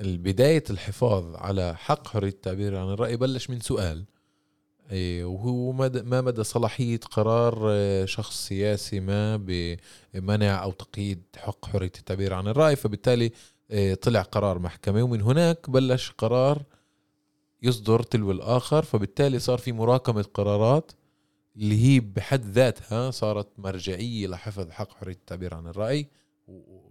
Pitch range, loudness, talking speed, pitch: 100-125 Hz, -26 LUFS, 125 wpm, 105 Hz